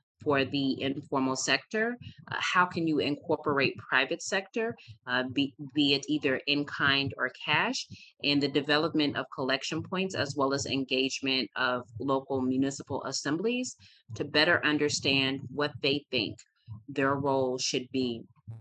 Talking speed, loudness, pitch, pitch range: 140 wpm, -29 LUFS, 140 Hz, 130-150 Hz